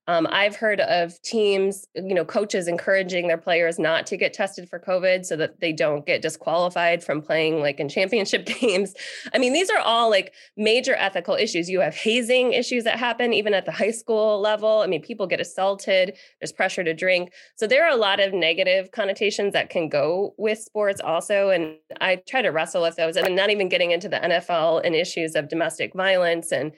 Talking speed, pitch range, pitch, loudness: 210 wpm, 170-215 Hz, 190 Hz, -22 LUFS